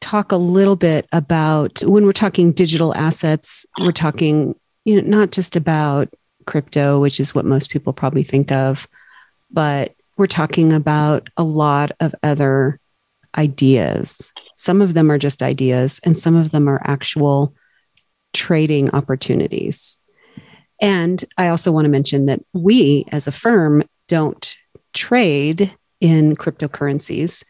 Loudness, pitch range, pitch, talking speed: -16 LUFS, 140-175 Hz, 155 Hz, 140 wpm